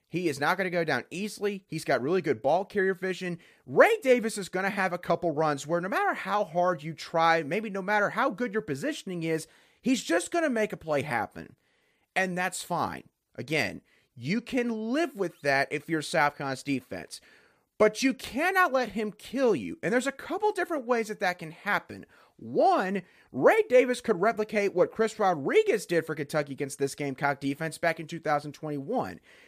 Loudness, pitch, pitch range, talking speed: -28 LUFS, 185 Hz, 160-225 Hz, 195 wpm